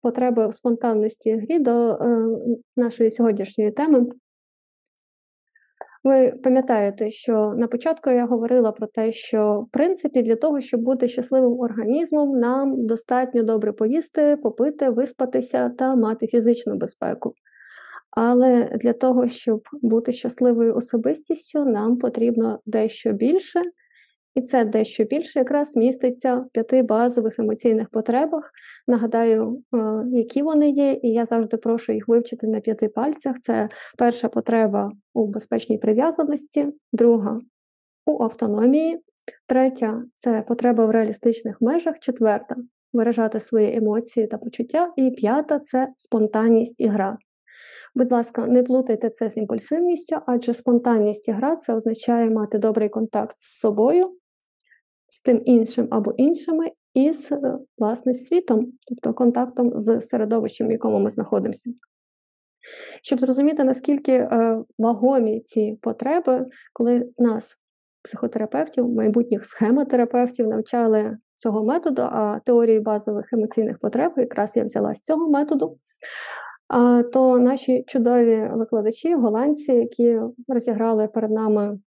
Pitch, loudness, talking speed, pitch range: 240 Hz, -21 LUFS, 125 wpm, 225-260 Hz